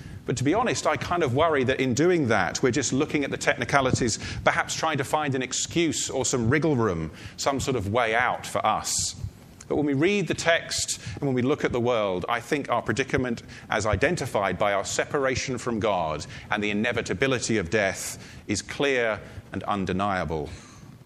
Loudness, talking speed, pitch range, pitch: -25 LUFS, 195 wpm, 110-145 Hz, 130 Hz